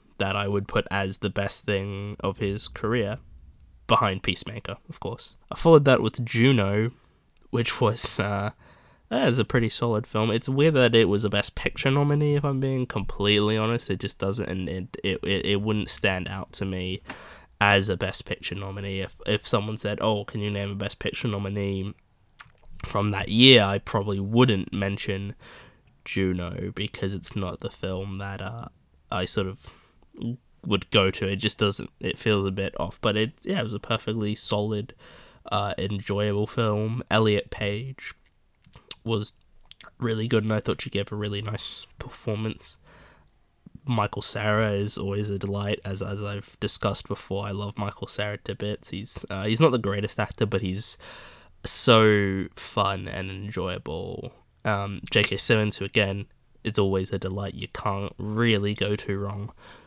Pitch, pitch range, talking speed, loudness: 105 Hz, 95-110 Hz, 170 wpm, -26 LUFS